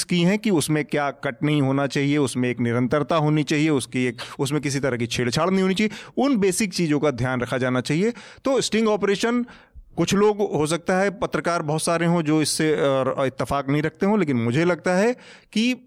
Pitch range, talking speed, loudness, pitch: 140-195 Hz, 210 wpm, -22 LUFS, 155 Hz